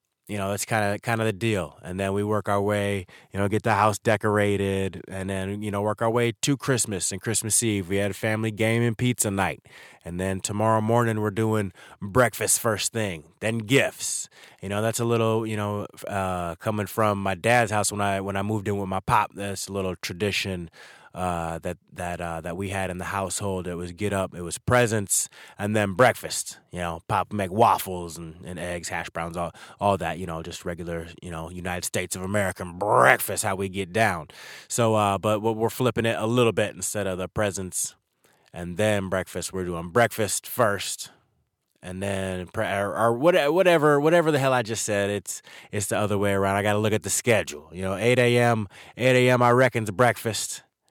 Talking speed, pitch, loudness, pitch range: 215 wpm, 100 Hz, -25 LUFS, 95-110 Hz